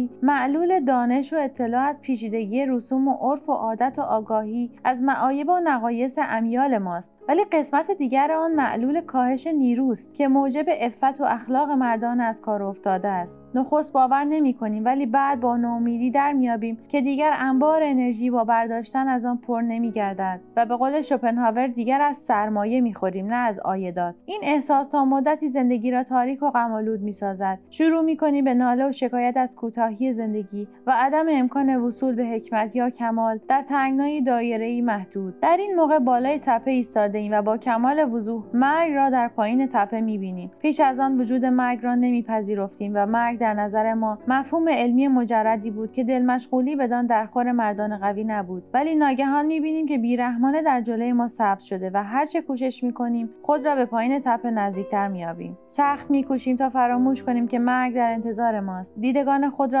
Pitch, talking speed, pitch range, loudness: 250 Hz, 175 wpm, 225-275 Hz, -22 LUFS